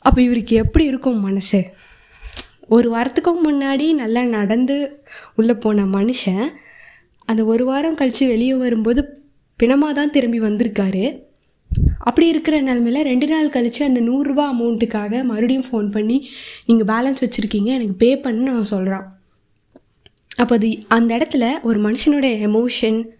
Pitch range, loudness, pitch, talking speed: 225-275 Hz, -17 LUFS, 240 Hz, 130 wpm